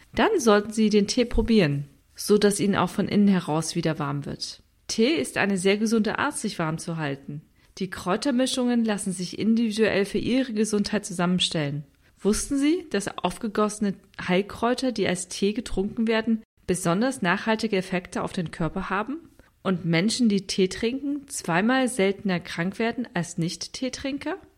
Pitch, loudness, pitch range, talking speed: 200 Hz, -25 LUFS, 180-230 Hz, 155 wpm